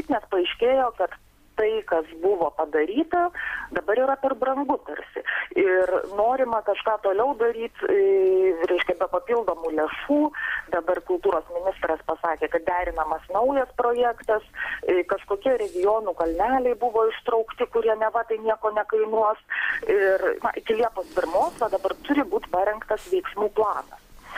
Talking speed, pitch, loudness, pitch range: 125 wpm, 220 Hz, -24 LUFS, 185-265 Hz